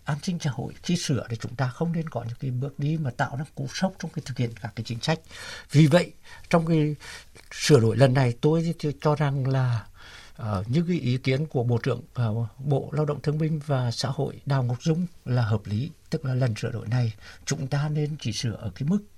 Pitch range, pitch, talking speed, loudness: 120-155 Hz, 140 Hz, 245 wpm, -26 LUFS